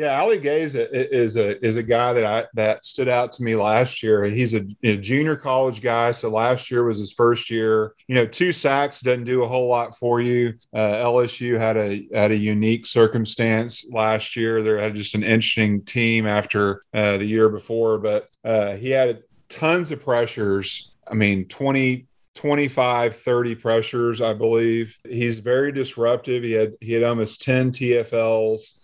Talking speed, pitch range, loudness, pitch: 180 wpm, 110-125 Hz, -21 LUFS, 115 Hz